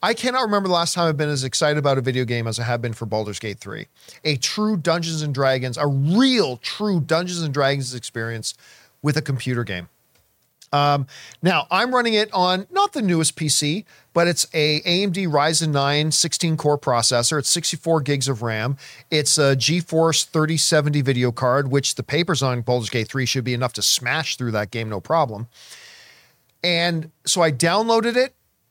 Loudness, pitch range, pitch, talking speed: -20 LUFS, 125-170 Hz, 150 Hz, 180 wpm